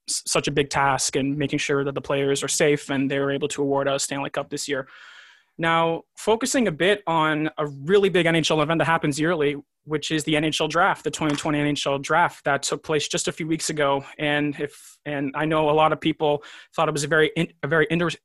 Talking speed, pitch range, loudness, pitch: 230 wpm, 145-165 Hz, -23 LUFS, 150 Hz